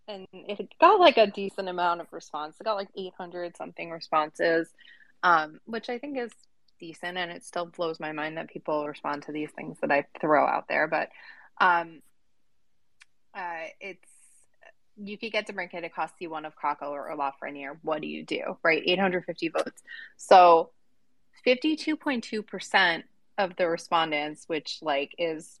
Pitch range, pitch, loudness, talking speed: 155-205 Hz, 175 Hz, -27 LUFS, 160 wpm